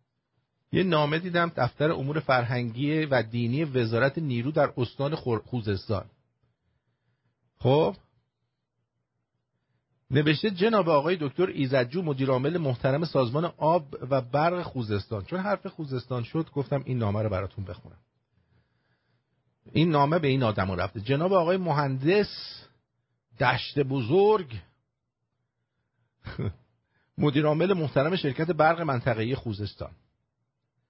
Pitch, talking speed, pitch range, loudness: 135 Hz, 105 wpm, 120-155 Hz, -26 LUFS